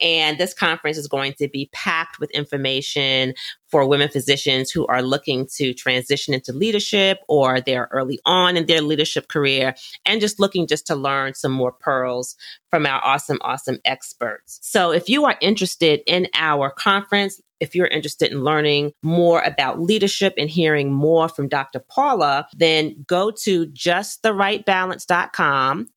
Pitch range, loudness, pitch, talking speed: 140-180 Hz, -19 LUFS, 150 Hz, 155 wpm